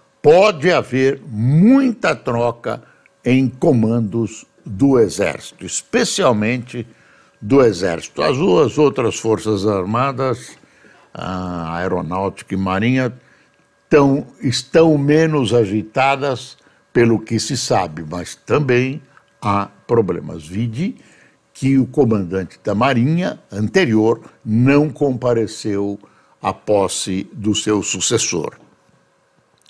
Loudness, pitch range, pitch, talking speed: -17 LUFS, 105-135 Hz, 115 Hz, 95 wpm